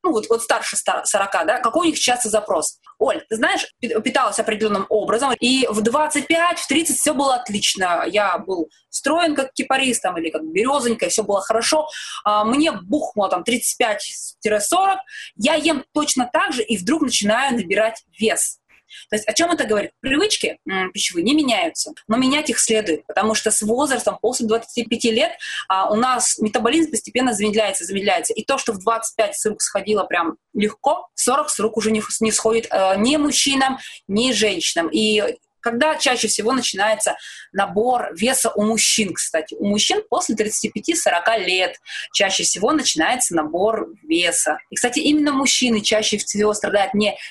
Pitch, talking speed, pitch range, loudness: 230 Hz, 165 wpm, 210-285 Hz, -19 LUFS